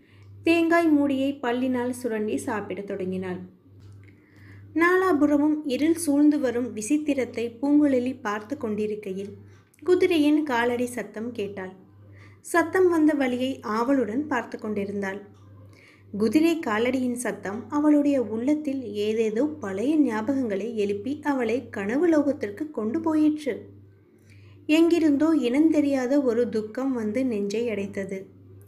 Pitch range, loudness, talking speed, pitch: 200-290 Hz, -24 LUFS, 95 wpm, 240 Hz